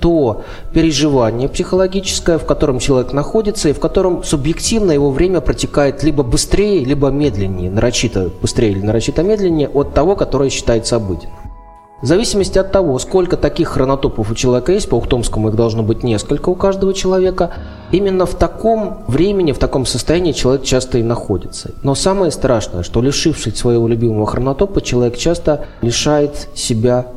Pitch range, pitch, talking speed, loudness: 120-175 Hz, 140 Hz, 155 wpm, -15 LUFS